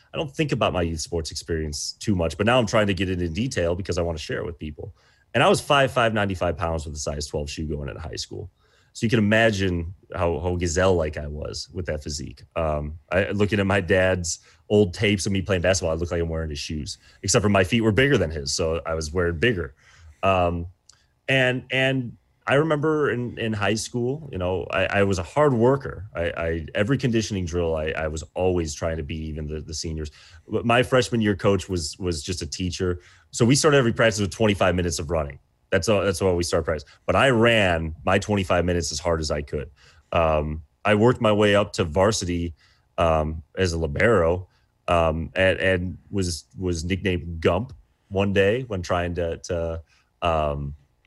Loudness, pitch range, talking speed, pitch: -23 LUFS, 80-105 Hz, 215 wpm, 90 Hz